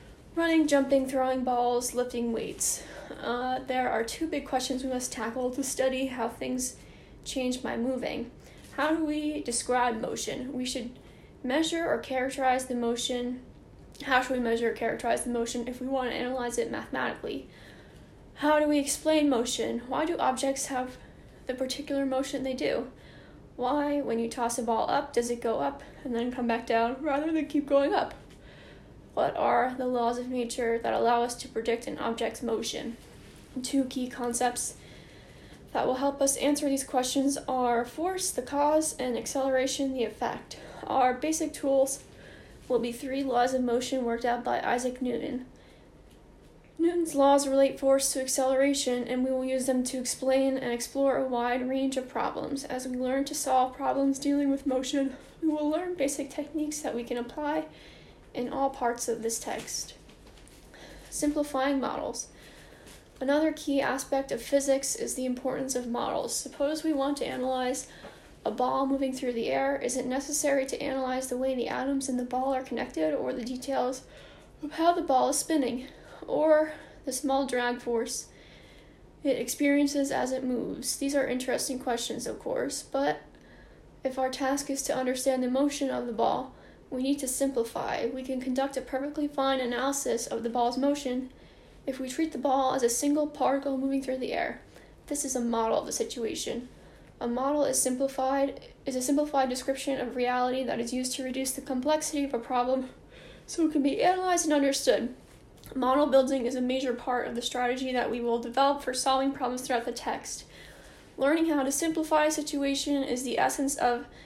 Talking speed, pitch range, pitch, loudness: 180 wpm, 250-280 Hz, 260 Hz, -29 LUFS